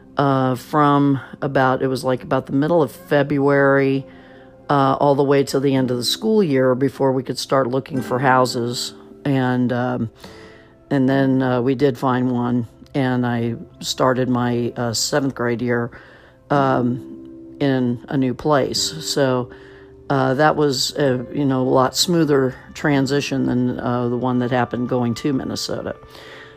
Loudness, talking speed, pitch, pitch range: -19 LUFS, 160 wpm, 130 Hz, 125-140 Hz